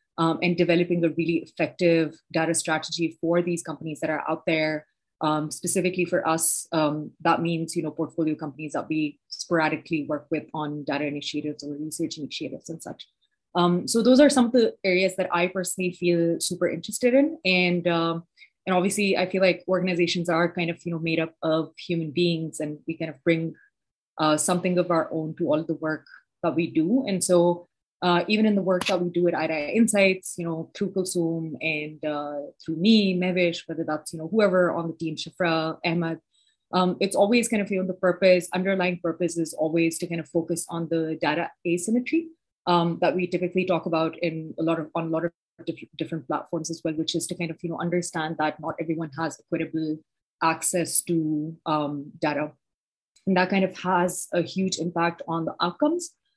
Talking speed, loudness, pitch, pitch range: 200 wpm, -25 LUFS, 170 Hz, 160-180 Hz